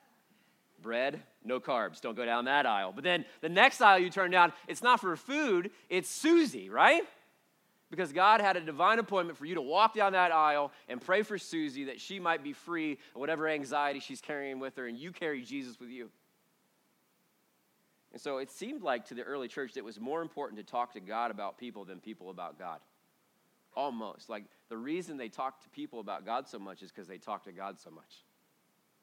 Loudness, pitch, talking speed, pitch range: -31 LUFS, 160 Hz, 210 wpm, 130-195 Hz